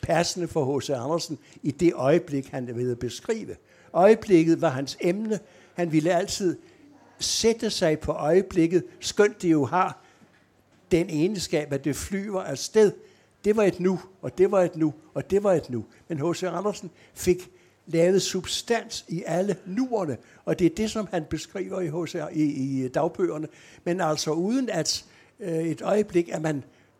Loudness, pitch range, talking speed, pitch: -25 LUFS, 155-190 Hz, 165 wpm, 170 Hz